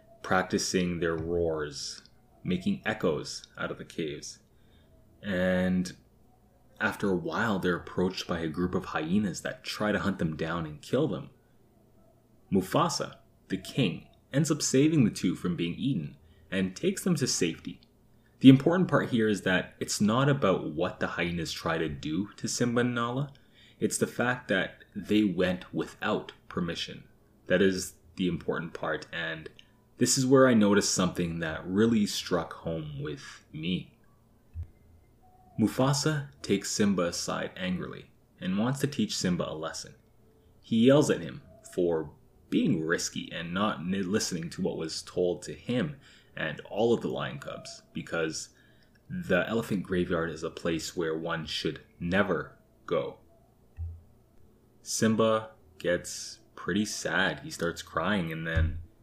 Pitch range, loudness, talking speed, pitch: 85-120 Hz, -29 LUFS, 150 wpm, 100 Hz